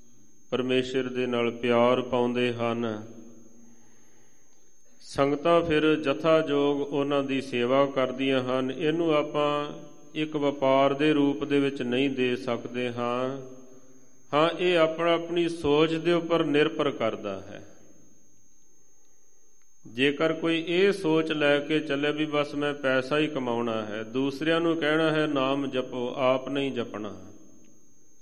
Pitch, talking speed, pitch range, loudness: 135 Hz, 130 wpm, 125-150 Hz, -26 LUFS